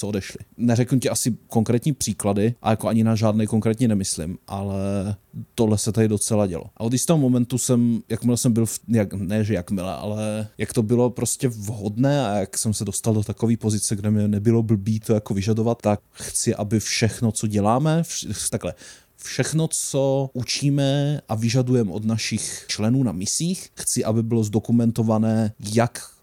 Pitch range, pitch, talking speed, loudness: 105-120 Hz, 110 Hz, 175 wpm, -22 LUFS